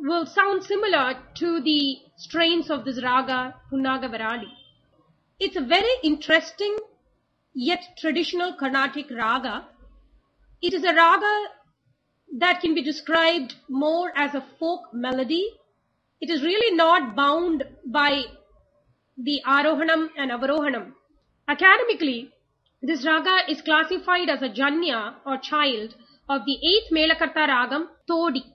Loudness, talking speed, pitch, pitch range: -22 LUFS, 120 wpm, 310 Hz, 270-340 Hz